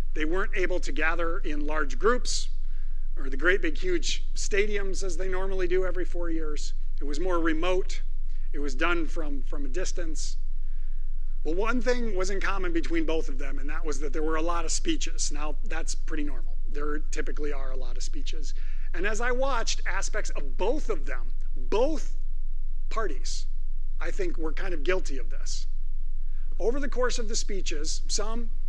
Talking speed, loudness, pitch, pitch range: 185 wpm, -31 LUFS, 180 Hz, 155-230 Hz